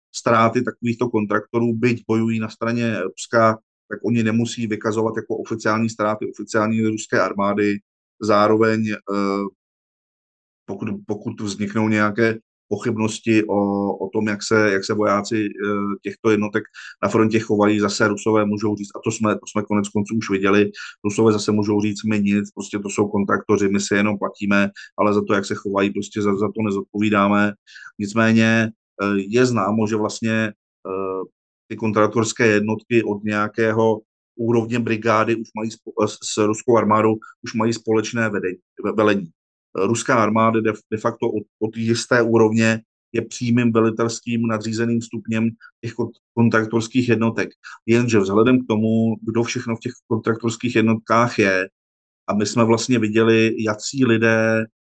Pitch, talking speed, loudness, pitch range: 110 Hz, 145 wpm, -20 LUFS, 105-115 Hz